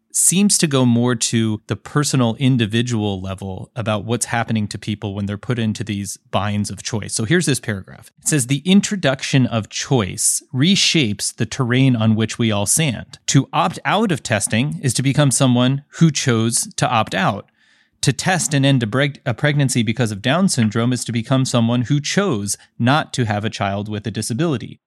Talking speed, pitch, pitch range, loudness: 195 wpm, 120 Hz, 110-140 Hz, -18 LUFS